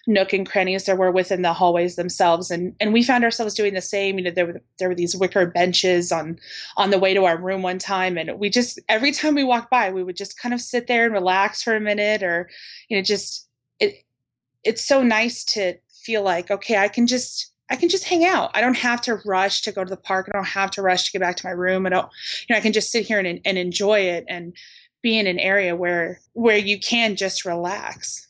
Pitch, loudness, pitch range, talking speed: 195 Hz, -20 LUFS, 180-225 Hz, 255 wpm